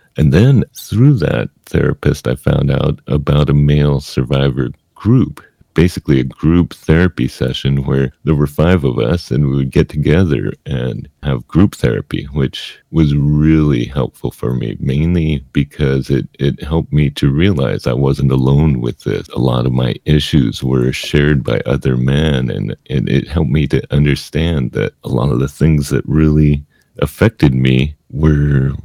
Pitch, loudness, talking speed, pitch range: 70 Hz, -14 LUFS, 165 wpm, 65-75 Hz